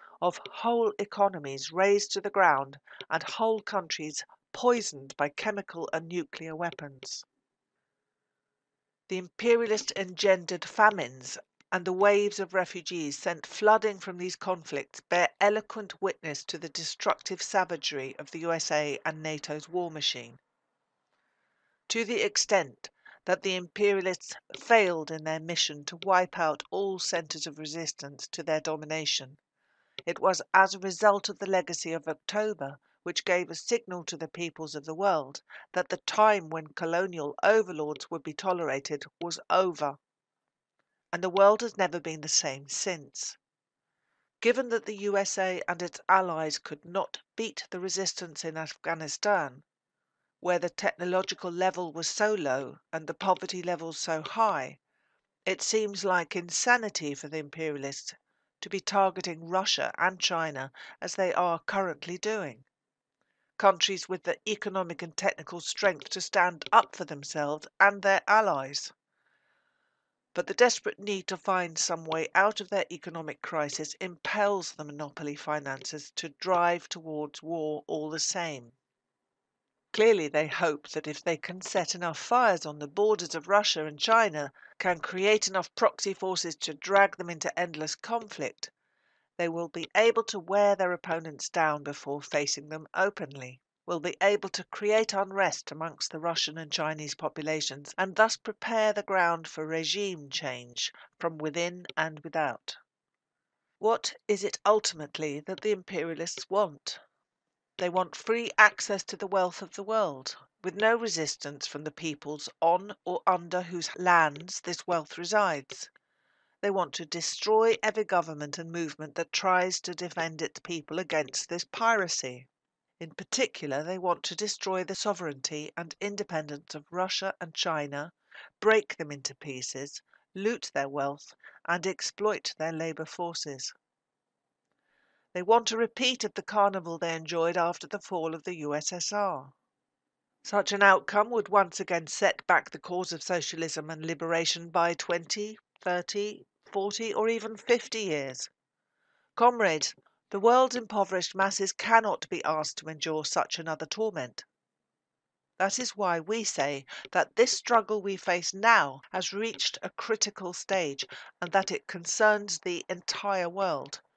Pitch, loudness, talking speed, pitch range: 180 Hz, -29 LUFS, 145 wpm, 155-200 Hz